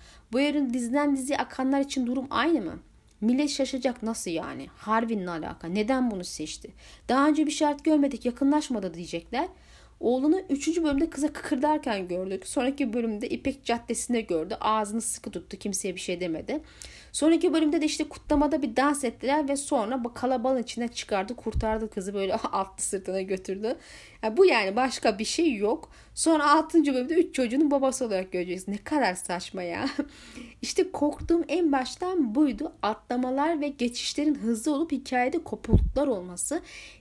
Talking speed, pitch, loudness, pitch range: 155 wpm, 260 Hz, -27 LUFS, 220-295 Hz